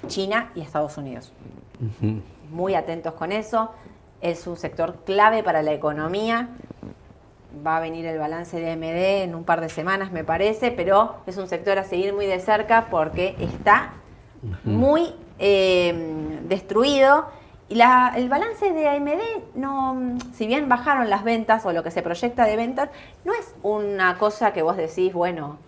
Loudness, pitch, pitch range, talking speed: -22 LUFS, 190 Hz, 165-230 Hz, 165 wpm